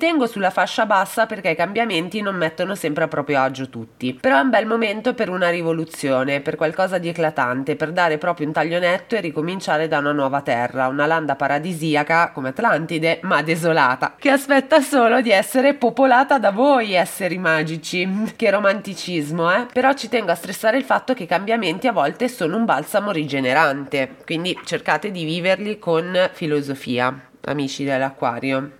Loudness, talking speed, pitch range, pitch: -19 LUFS, 170 wpm, 150-210 Hz, 170 Hz